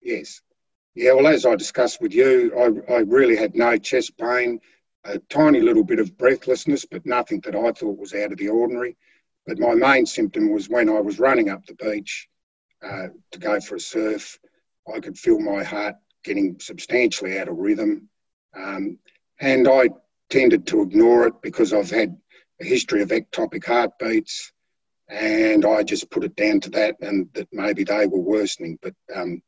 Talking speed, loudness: 185 wpm, -20 LUFS